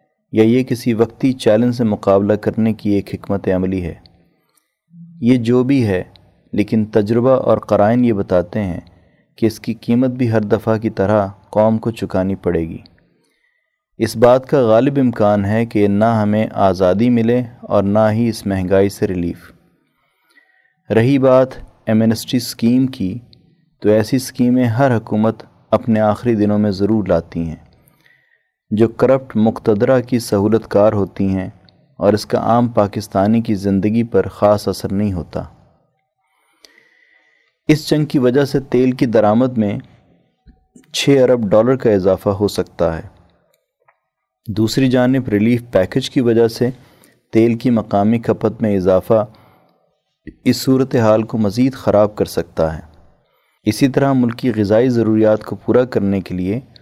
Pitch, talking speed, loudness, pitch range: 110 Hz, 150 wpm, -16 LUFS, 100-125 Hz